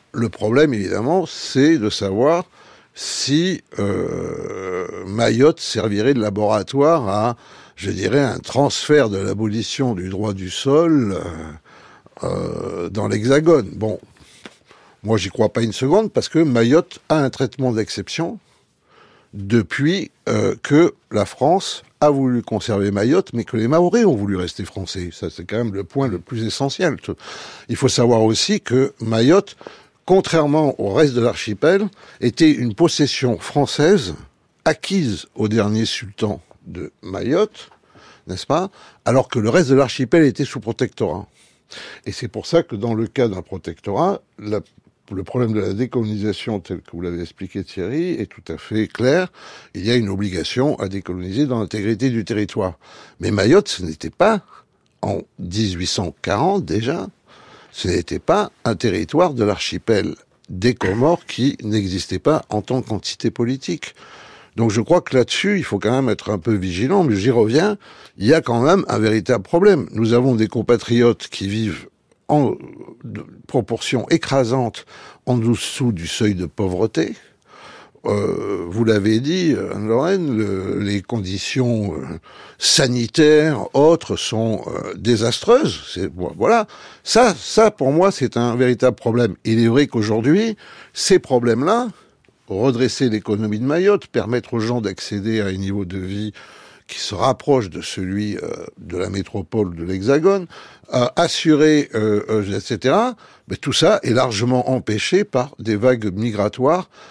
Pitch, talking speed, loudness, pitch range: 115 Hz, 150 wpm, -19 LUFS, 105-135 Hz